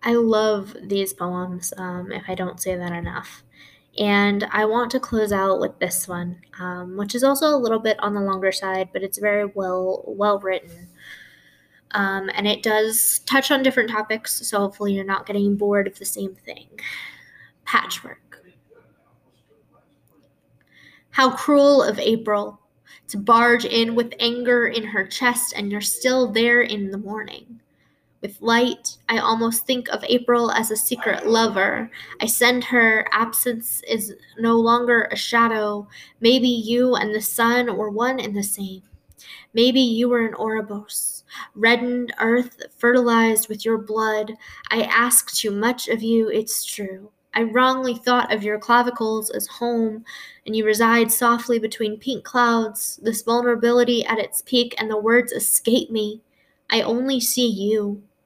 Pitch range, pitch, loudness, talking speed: 205-240 Hz, 225 Hz, -20 LUFS, 160 wpm